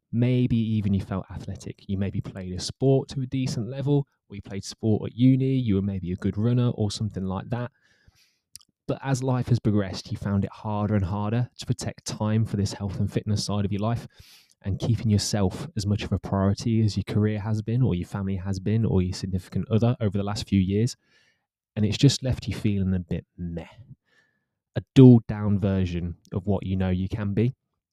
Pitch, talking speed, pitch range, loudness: 105 Hz, 215 wpm, 95-120 Hz, -25 LUFS